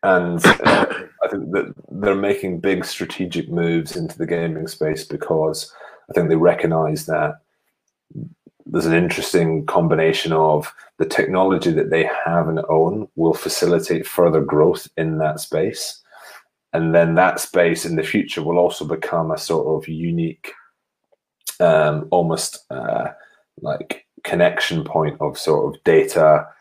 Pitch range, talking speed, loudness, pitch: 80-90 Hz, 140 wpm, -19 LUFS, 85 Hz